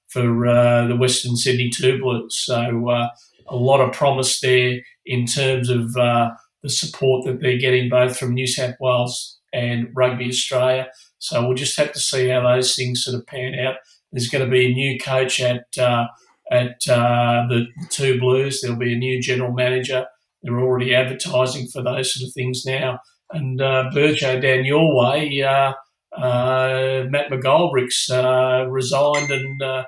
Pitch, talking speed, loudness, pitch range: 130 Hz, 175 wpm, -19 LUFS, 125-130 Hz